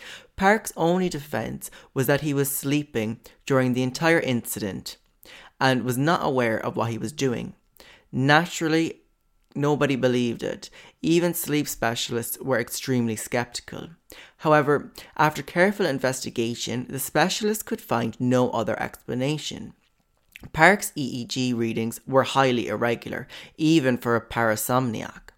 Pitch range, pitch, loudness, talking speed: 120-155 Hz, 130 Hz, -24 LUFS, 125 wpm